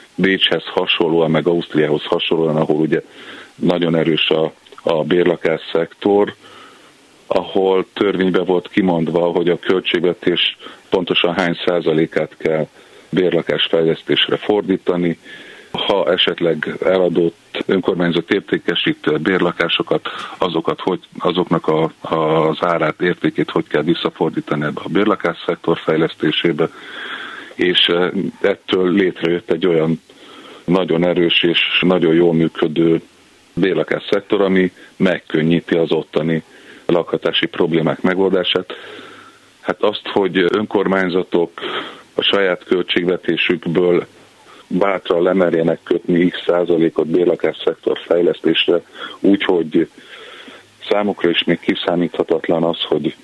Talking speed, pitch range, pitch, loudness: 105 wpm, 80-95 Hz, 85 Hz, -17 LUFS